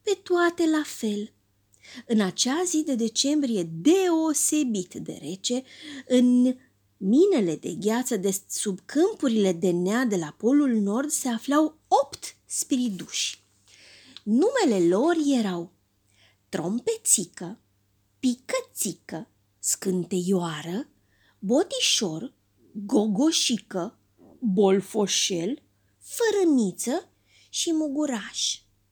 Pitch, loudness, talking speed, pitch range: 230 Hz, -25 LUFS, 85 wpm, 180-295 Hz